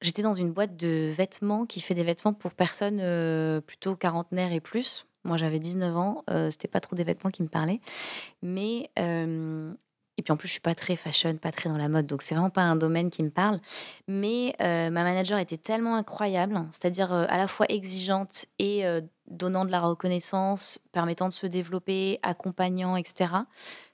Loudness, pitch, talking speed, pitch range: -28 LUFS, 180 Hz, 195 wpm, 170-195 Hz